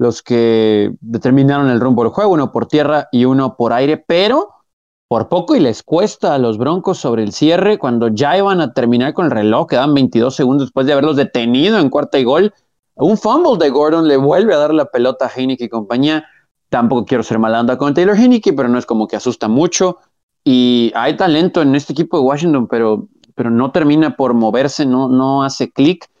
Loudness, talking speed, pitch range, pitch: -13 LUFS, 210 wpm, 120-150 Hz, 130 Hz